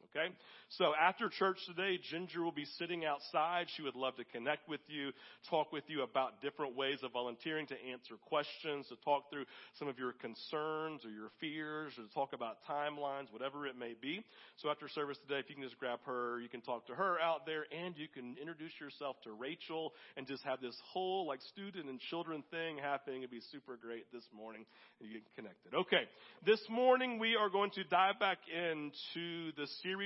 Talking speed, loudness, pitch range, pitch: 210 wpm, -40 LUFS, 130-165 Hz, 145 Hz